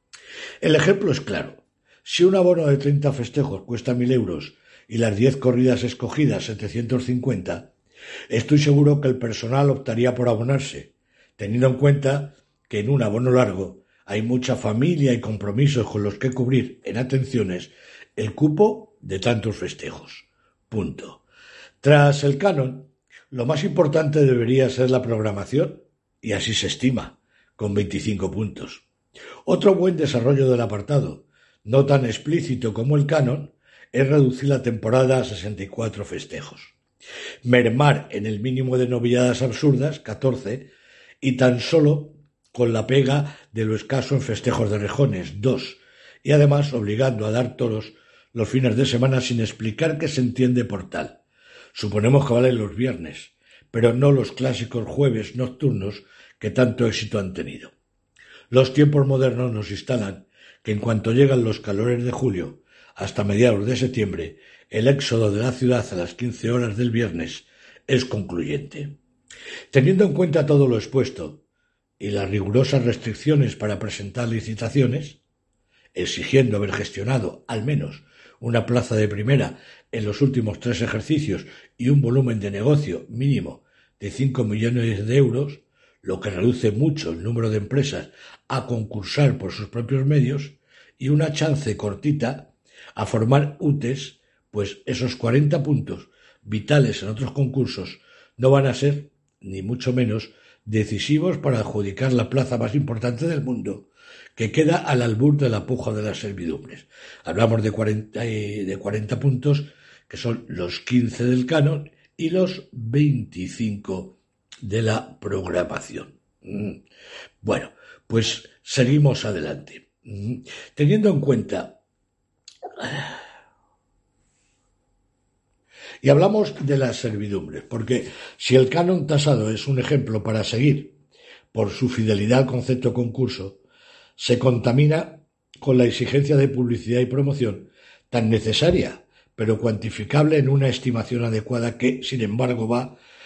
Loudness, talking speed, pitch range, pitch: -22 LUFS, 140 wpm, 110-140 Hz, 125 Hz